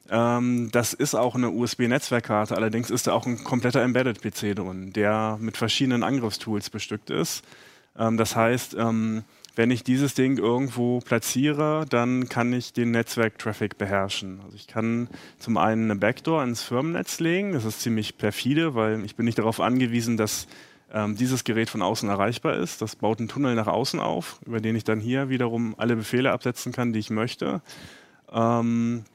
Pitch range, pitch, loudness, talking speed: 110-125 Hz, 115 Hz, -25 LUFS, 165 wpm